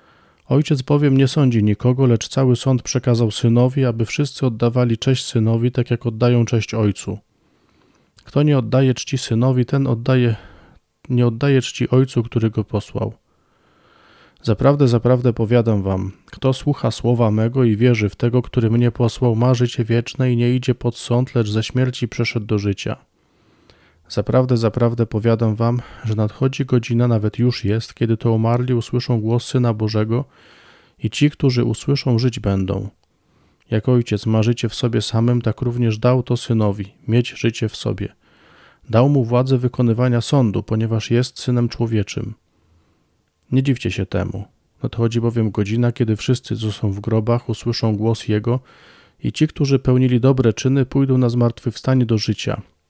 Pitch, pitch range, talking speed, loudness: 120 Hz, 110-125 Hz, 155 wpm, -18 LUFS